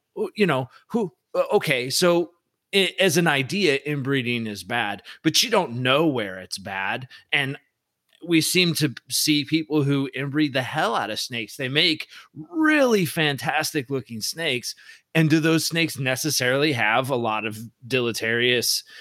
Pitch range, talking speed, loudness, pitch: 125-165 Hz, 150 wpm, -22 LUFS, 145 Hz